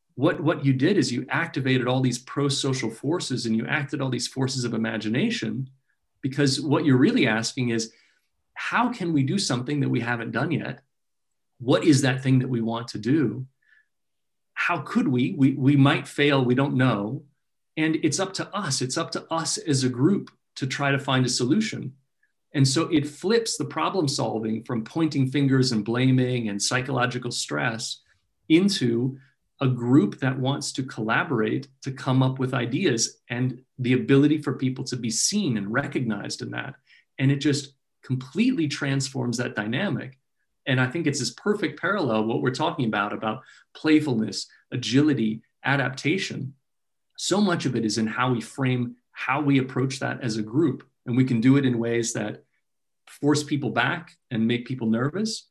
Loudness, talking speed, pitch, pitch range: -24 LUFS, 180 wpm, 130 Hz, 120-145 Hz